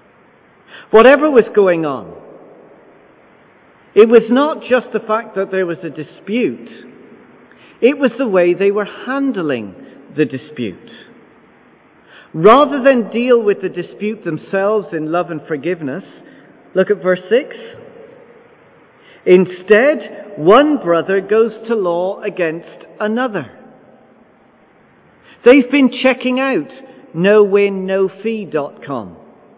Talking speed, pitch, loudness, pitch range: 110 wpm, 210 Hz, -14 LUFS, 185-255 Hz